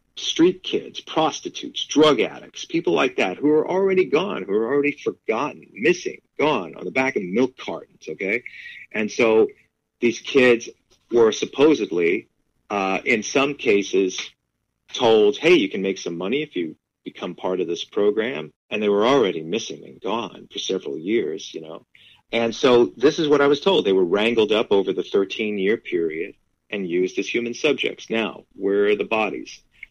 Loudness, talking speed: -21 LUFS, 175 wpm